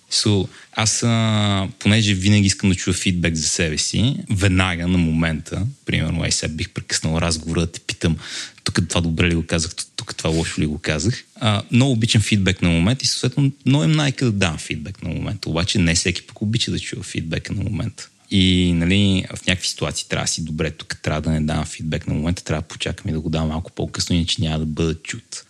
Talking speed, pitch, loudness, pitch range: 225 wpm, 90 Hz, -20 LUFS, 80-110 Hz